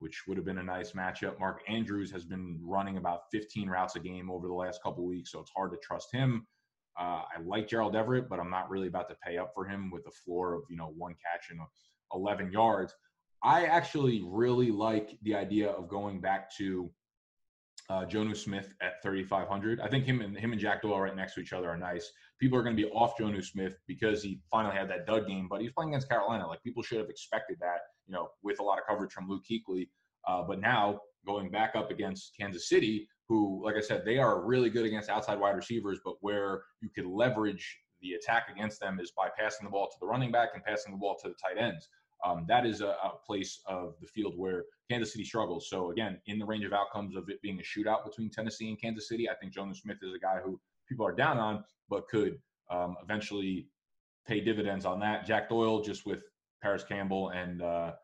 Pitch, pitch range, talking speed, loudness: 100 Hz, 95-110 Hz, 235 wpm, -34 LUFS